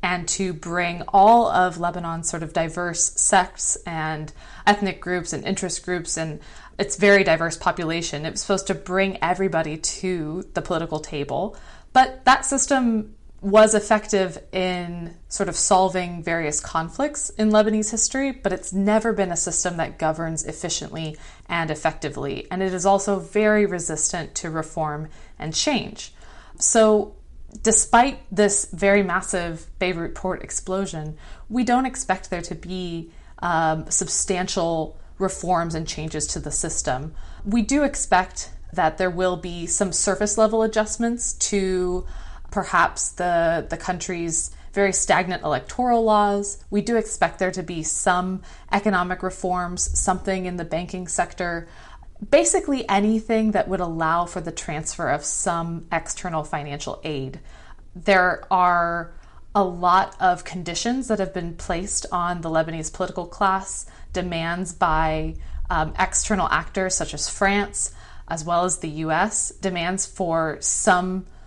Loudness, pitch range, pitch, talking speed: -22 LUFS, 165-200 Hz, 180 Hz, 140 wpm